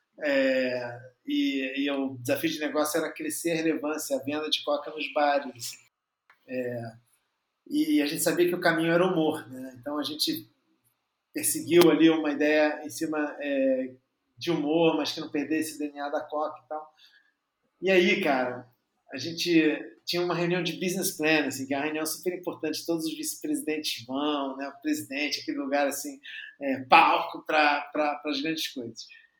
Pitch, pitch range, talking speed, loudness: 155 Hz, 145-175 Hz, 175 wpm, -27 LUFS